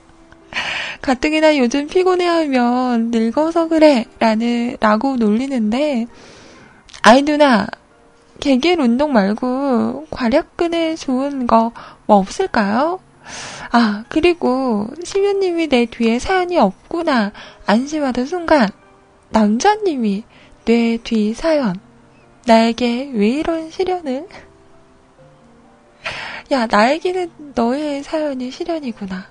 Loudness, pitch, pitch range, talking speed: -17 LUFS, 260 Hz, 230-315 Hz, 205 characters per minute